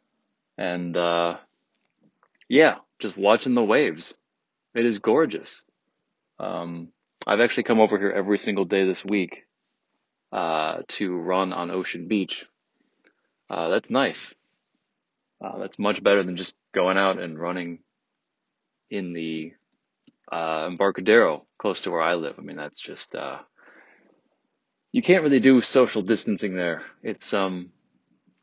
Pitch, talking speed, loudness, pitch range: 95 Hz, 135 wpm, -24 LUFS, 85-100 Hz